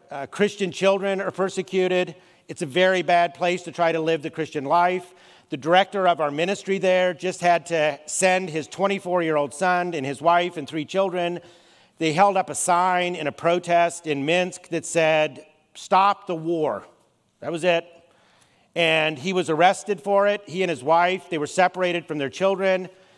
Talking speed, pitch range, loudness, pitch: 180 wpm, 160-185 Hz, -22 LUFS, 175 Hz